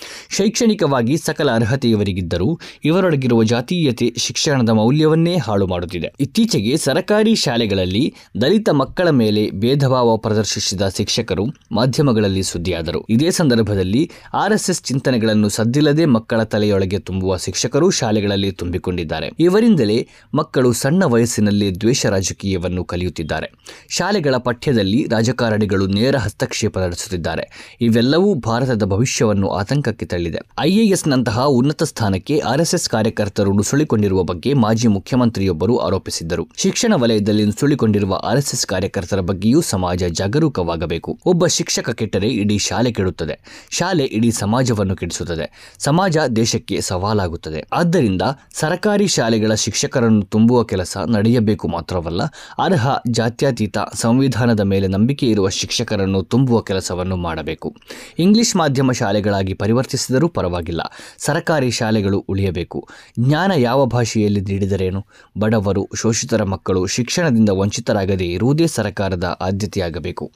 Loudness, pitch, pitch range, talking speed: -17 LUFS, 110 Hz, 95-135 Hz, 105 wpm